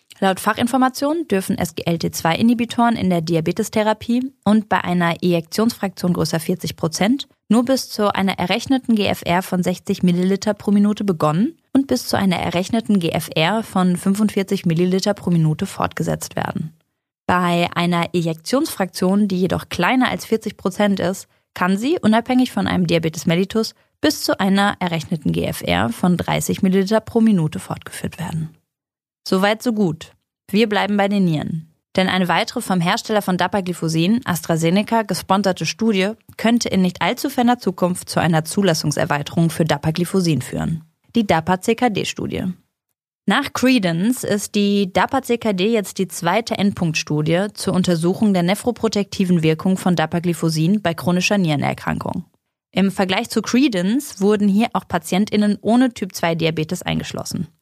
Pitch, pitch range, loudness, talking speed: 190 Hz, 175-215 Hz, -19 LUFS, 135 wpm